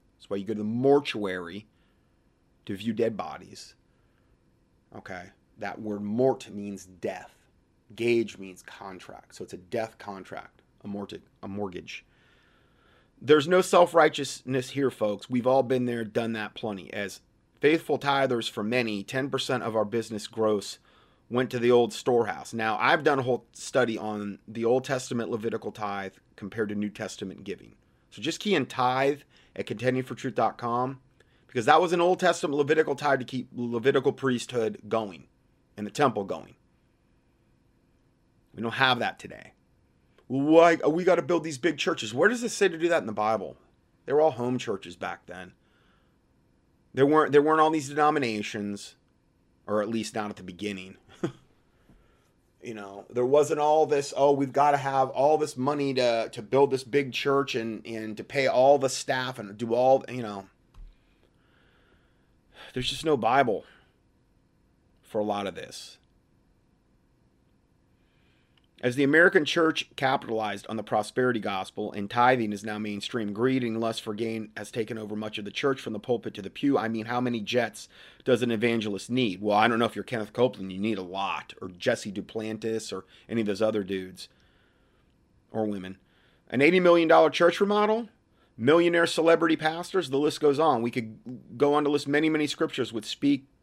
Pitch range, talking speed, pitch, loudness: 105-140 Hz, 175 wpm, 120 Hz, -26 LUFS